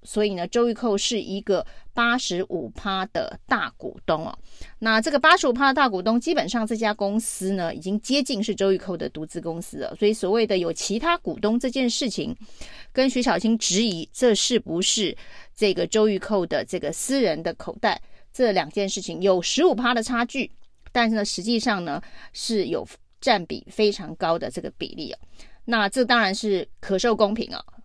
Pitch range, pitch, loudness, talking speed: 195-240 Hz, 215 Hz, -23 LUFS, 285 characters per minute